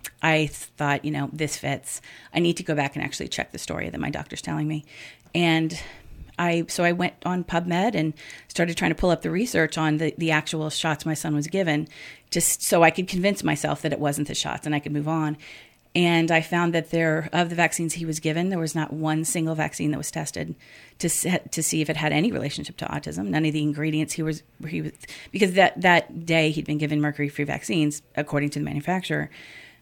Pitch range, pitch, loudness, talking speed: 150-170 Hz, 160 Hz, -24 LUFS, 225 wpm